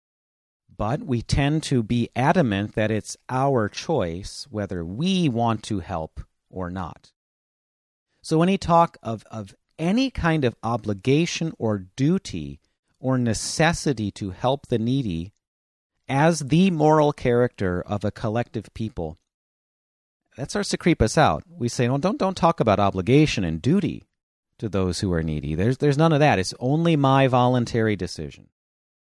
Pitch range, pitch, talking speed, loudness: 100-150 Hz, 120 Hz, 150 wpm, -23 LUFS